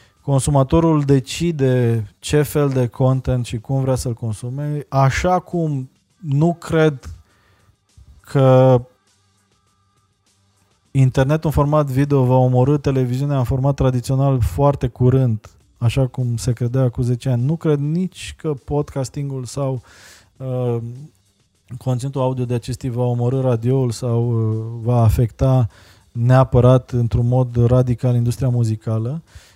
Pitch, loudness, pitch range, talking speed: 125 Hz, -18 LUFS, 115-135 Hz, 120 wpm